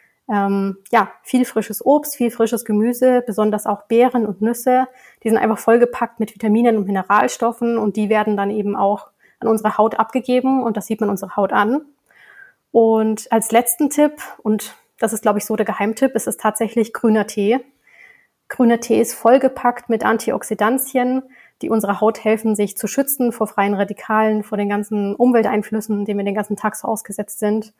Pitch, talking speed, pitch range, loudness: 220 Hz, 180 wpm, 210-245 Hz, -18 LUFS